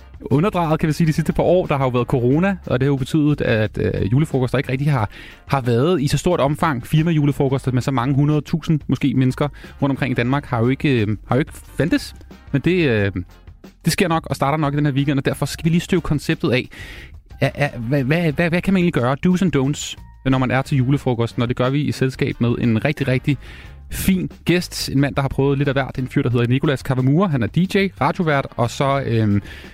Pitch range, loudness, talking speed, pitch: 125-155 Hz, -19 LUFS, 235 wpm, 140 Hz